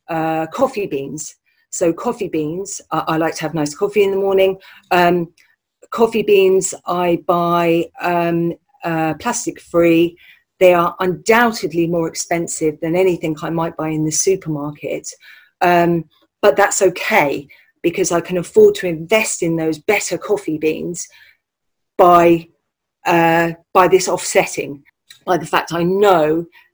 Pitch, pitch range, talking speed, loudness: 175 Hz, 165-200 Hz, 140 wpm, -16 LUFS